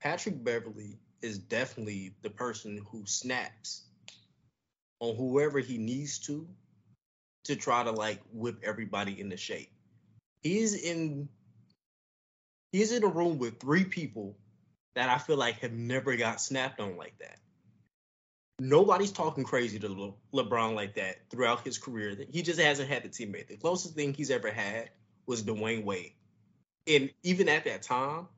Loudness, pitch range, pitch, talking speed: -32 LUFS, 105-145 Hz, 120 Hz, 150 wpm